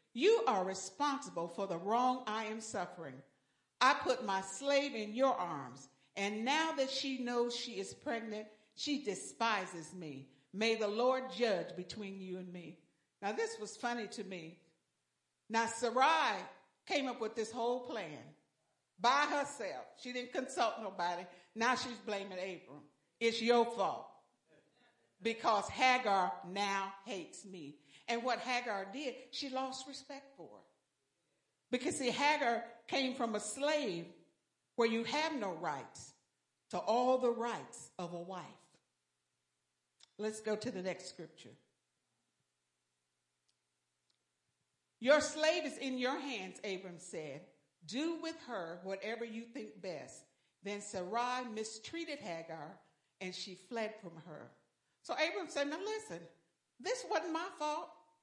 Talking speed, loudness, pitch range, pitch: 135 wpm, -37 LUFS, 175-255 Hz, 215 Hz